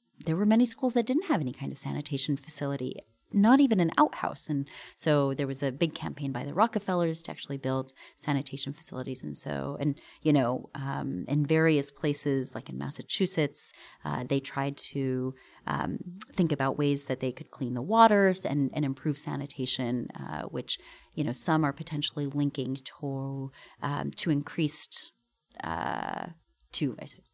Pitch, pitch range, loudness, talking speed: 145 Hz, 135-160 Hz, -29 LUFS, 170 wpm